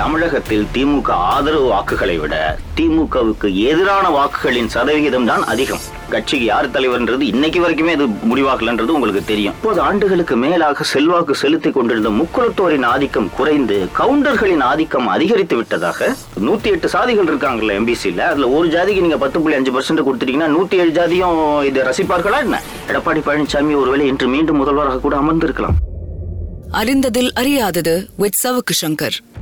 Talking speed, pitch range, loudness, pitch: 130 wpm, 130-190 Hz, -15 LUFS, 155 Hz